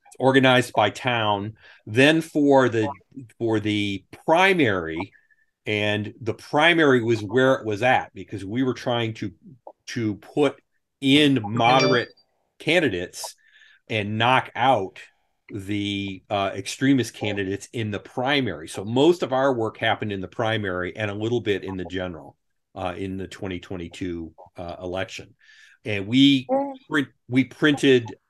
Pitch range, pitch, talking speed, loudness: 100-130 Hz, 110 Hz, 135 wpm, -22 LUFS